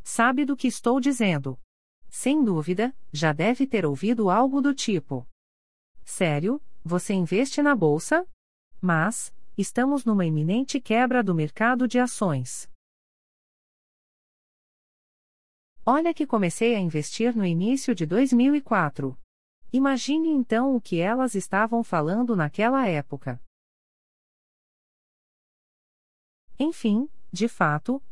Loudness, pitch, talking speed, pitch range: -24 LUFS, 220 Hz, 105 wpm, 155-255 Hz